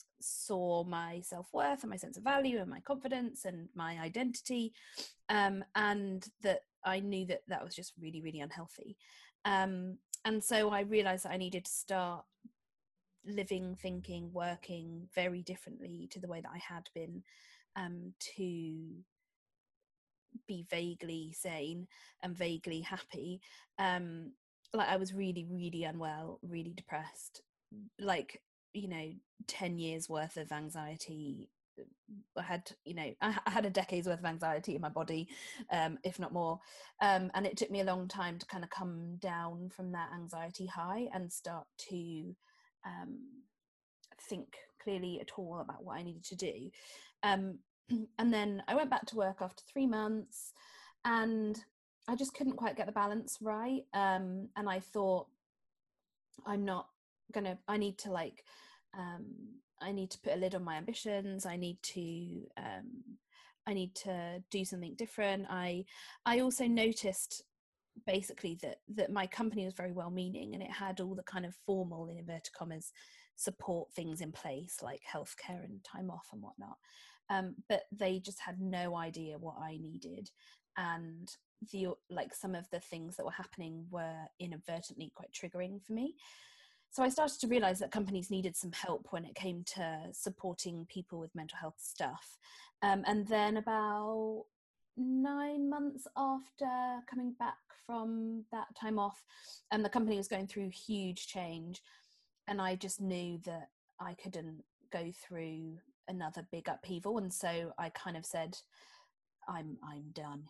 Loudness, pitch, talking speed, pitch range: -39 LUFS, 190 Hz, 160 wpm, 175-220 Hz